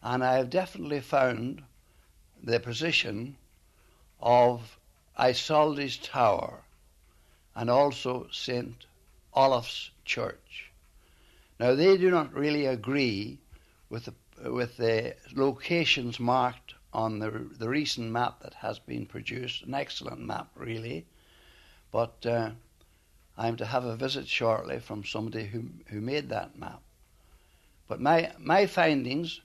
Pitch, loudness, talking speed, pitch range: 120 Hz, -29 LUFS, 120 wpm, 95-130 Hz